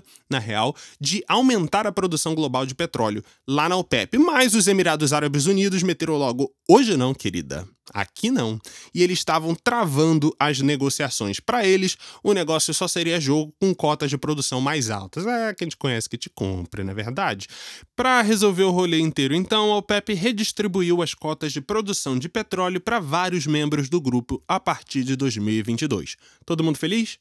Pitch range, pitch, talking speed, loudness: 135-190 Hz, 160 Hz, 175 wpm, -22 LUFS